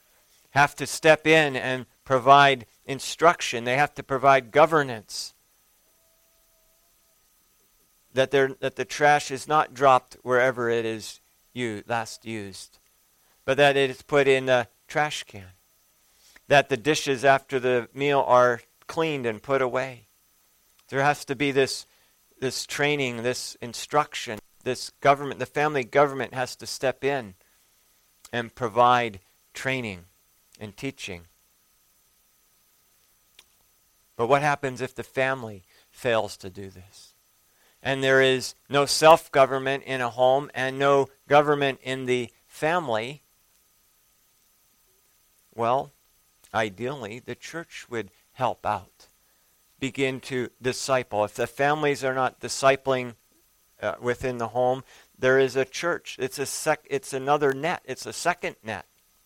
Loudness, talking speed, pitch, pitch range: -24 LUFS, 130 wpm, 130 Hz, 120-140 Hz